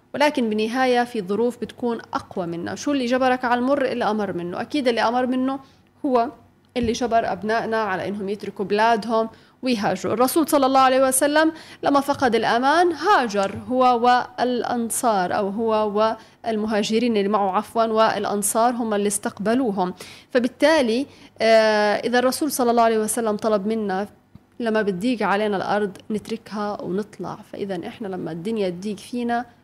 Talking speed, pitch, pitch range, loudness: 140 wpm, 225 Hz, 210-250 Hz, -21 LUFS